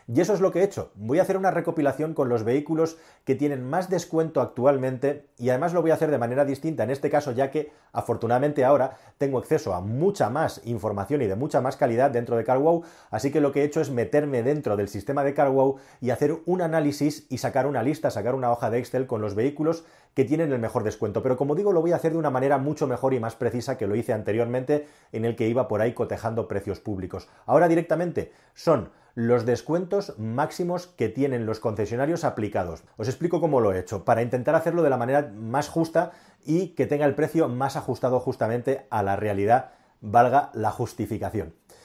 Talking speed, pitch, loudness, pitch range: 215 wpm, 135 Hz, -25 LUFS, 120-155 Hz